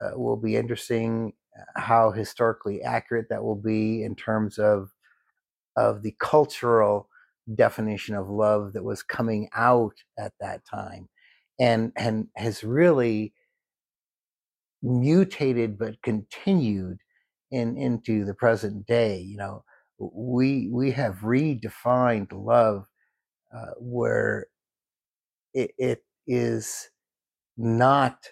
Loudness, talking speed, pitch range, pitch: -25 LUFS, 110 wpm, 105-125 Hz, 115 Hz